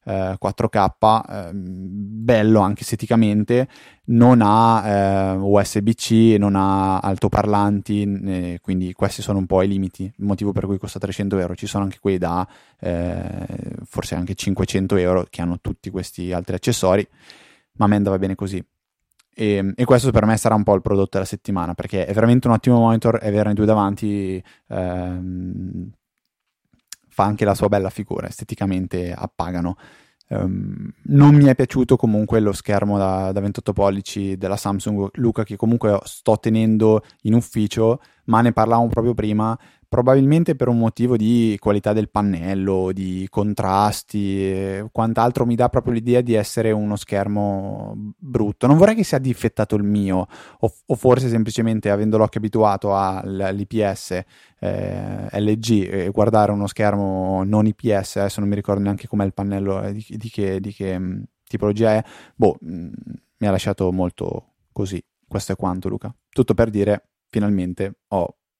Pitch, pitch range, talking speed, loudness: 105 Hz, 95-110 Hz, 155 wpm, -19 LUFS